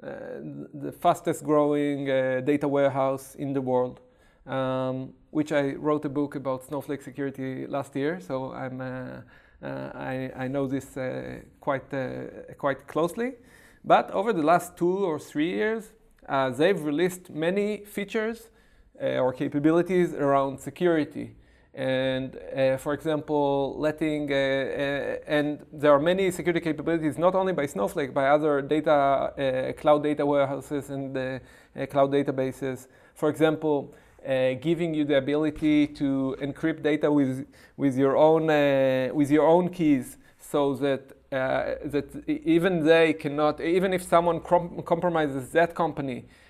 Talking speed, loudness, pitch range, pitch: 145 wpm, -26 LUFS, 135-160 Hz, 145 Hz